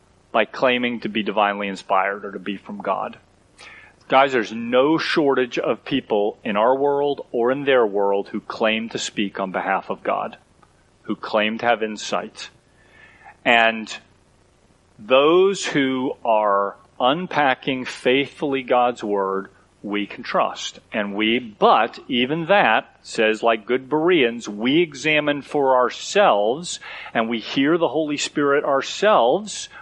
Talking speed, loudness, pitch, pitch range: 135 wpm, -20 LUFS, 120 Hz, 105-140 Hz